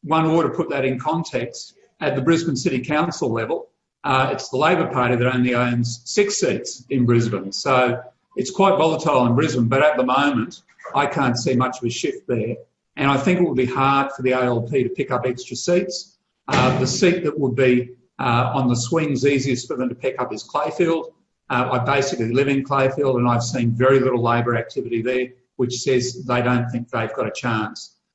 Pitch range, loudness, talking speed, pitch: 125-150 Hz, -20 LUFS, 210 wpm, 130 Hz